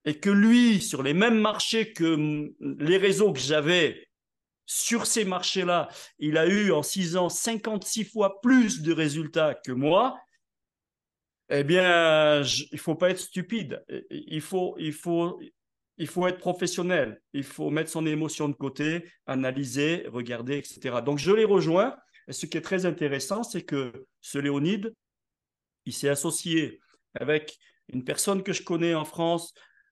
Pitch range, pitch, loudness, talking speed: 150-195 Hz, 170 Hz, -26 LUFS, 160 wpm